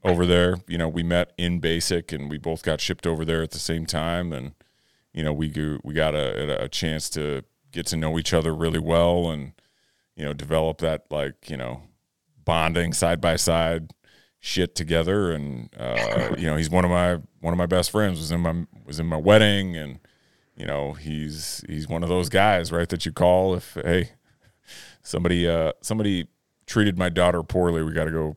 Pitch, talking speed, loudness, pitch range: 85 Hz, 205 wpm, -24 LUFS, 80-90 Hz